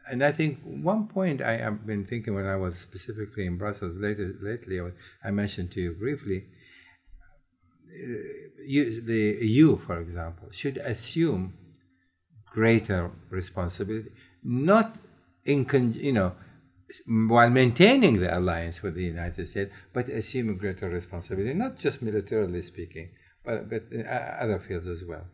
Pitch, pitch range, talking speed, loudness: 105 Hz, 90-125 Hz, 135 wpm, -27 LUFS